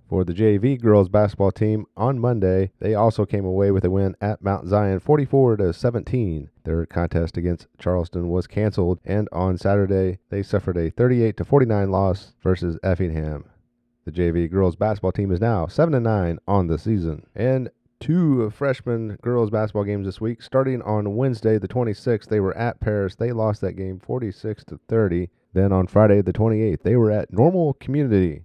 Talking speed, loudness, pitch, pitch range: 180 wpm, -21 LUFS, 105 Hz, 95-115 Hz